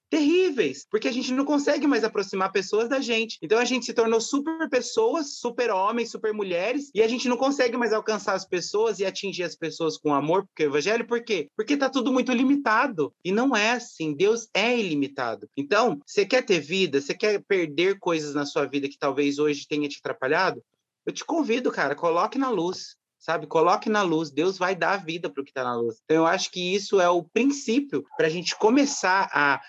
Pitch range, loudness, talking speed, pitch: 170-250 Hz, -24 LUFS, 215 wpm, 215 Hz